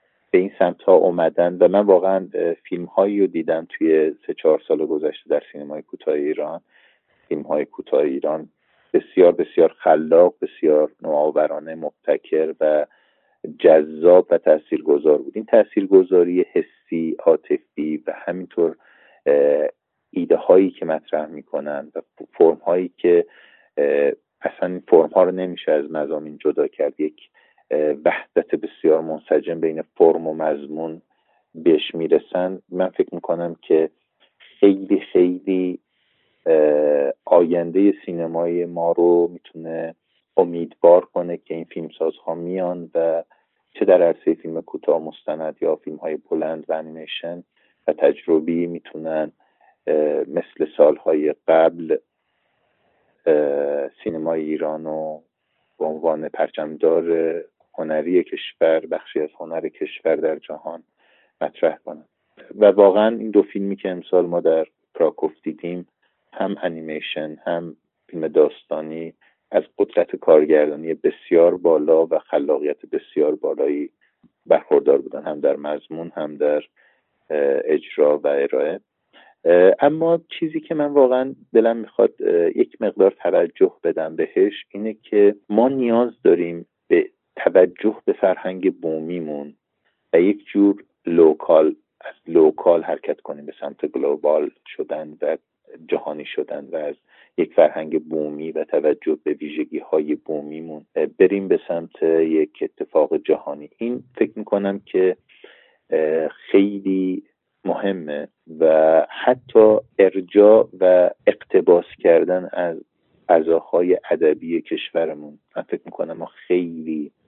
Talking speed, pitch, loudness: 120 wpm, 360 Hz, -19 LUFS